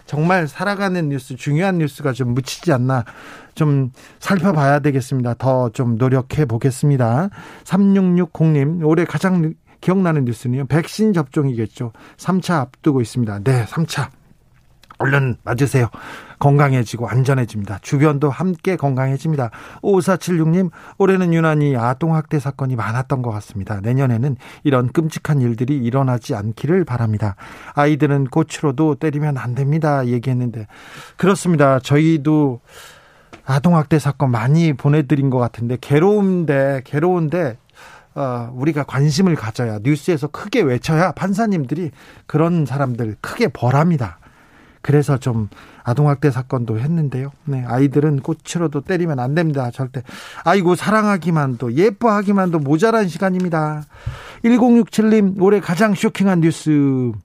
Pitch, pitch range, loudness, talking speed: 145 Hz, 130-170 Hz, -18 LUFS, 310 characters per minute